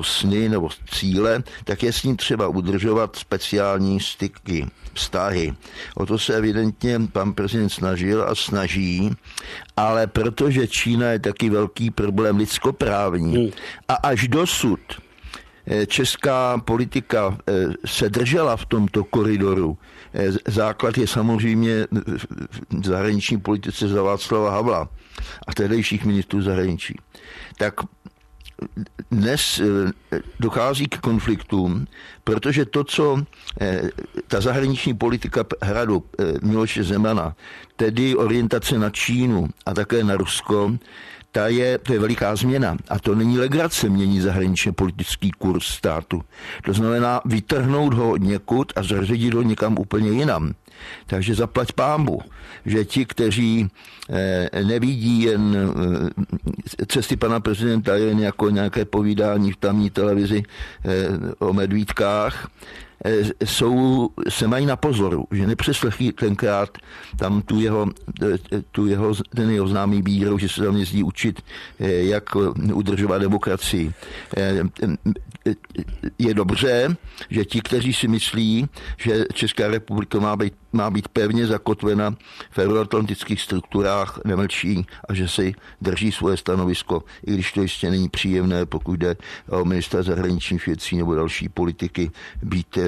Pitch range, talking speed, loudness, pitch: 95-115 Hz, 120 wpm, -21 LUFS, 105 Hz